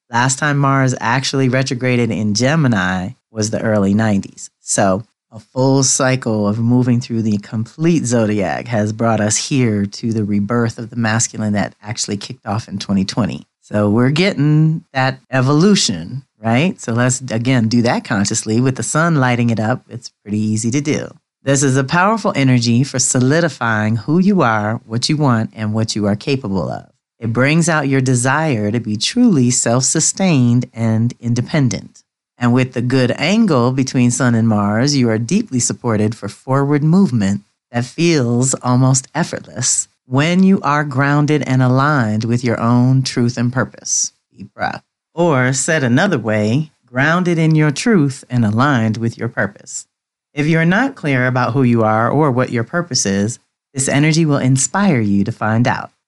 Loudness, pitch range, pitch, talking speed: -15 LUFS, 110-140 Hz, 125 Hz, 170 wpm